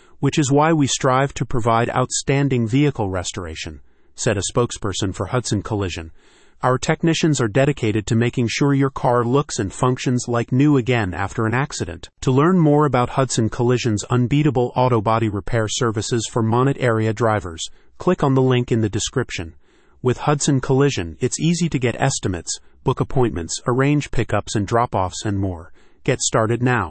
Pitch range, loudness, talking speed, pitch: 110-135 Hz, -19 LUFS, 170 wpm, 120 Hz